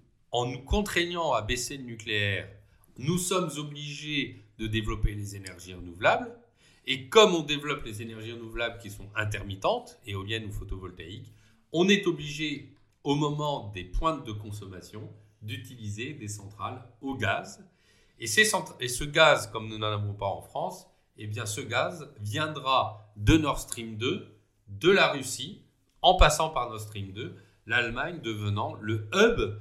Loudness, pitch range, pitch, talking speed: -28 LUFS, 105-140 Hz, 110 Hz, 155 wpm